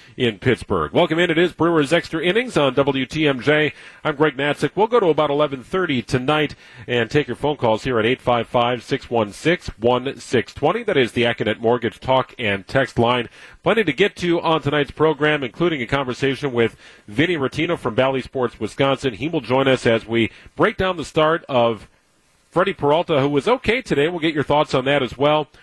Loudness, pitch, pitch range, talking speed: -19 LUFS, 140 Hz, 120-155 Hz, 205 wpm